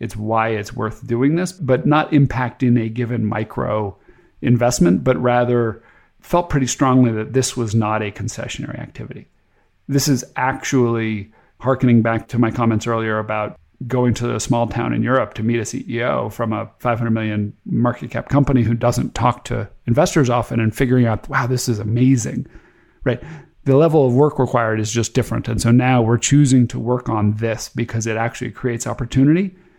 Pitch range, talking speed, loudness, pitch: 115-130 Hz, 180 wpm, -18 LUFS, 120 Hz